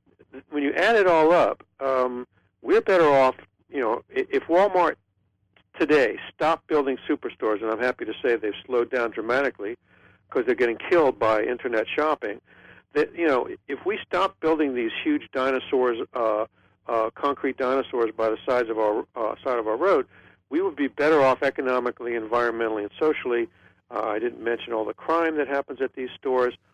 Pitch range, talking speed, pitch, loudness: 115-180 Hz, 175 wpm, 135 Hz, -24 LUFS